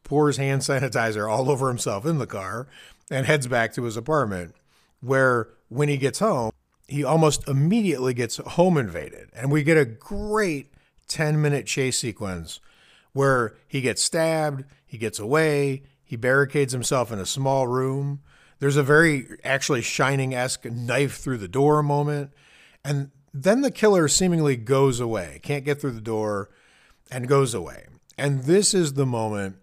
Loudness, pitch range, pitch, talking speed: -23 LUFS, 125-150 Hz, 135 Hz, 160 wpm